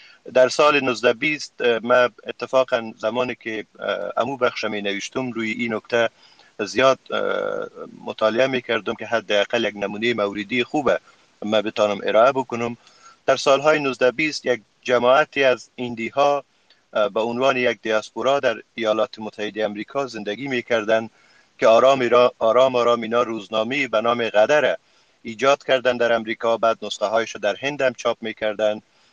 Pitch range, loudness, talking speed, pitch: 110-130 Hz, -21 LUFS, 140 wpm, 120 Hz